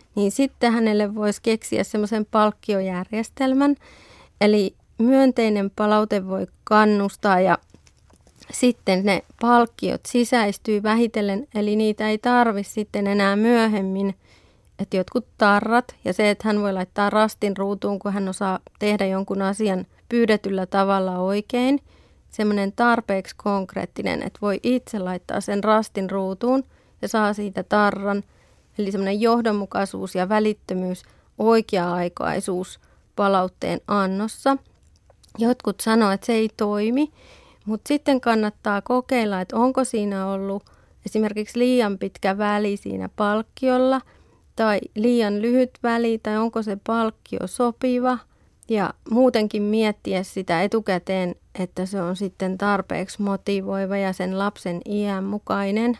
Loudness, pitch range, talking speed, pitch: -22 LUFS, 195-225 Hz, 120 wpm, 210 Hz